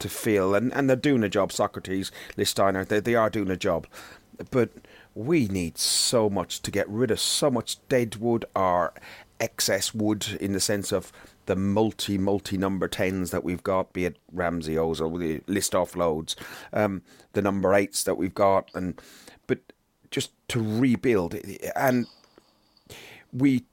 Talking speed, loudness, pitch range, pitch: 165 wpm, -26 LUFS, 95-110 Hz, 100 Hz